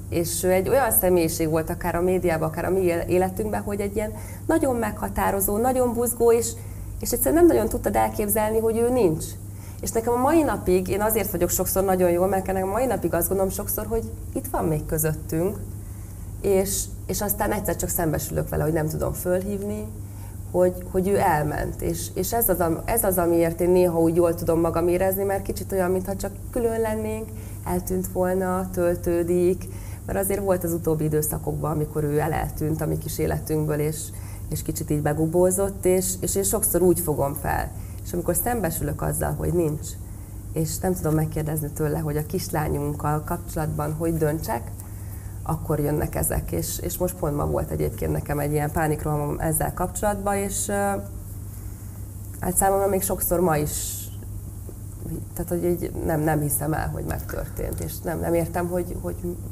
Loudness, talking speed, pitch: -24 LUFS, 175 wpm, 150 Hz